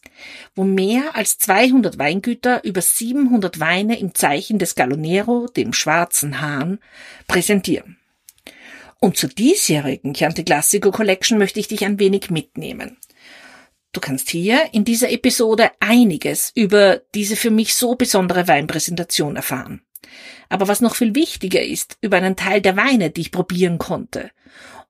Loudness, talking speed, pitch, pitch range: -17 LUFS, 140 wpm, 205 Hz, 180-240 Hz